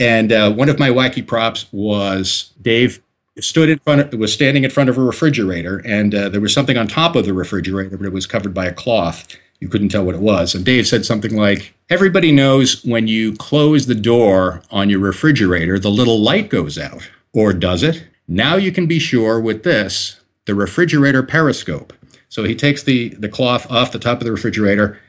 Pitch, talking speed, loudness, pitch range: 115 Hz, 210 wpm, -15 LUFS, 100-130 Hz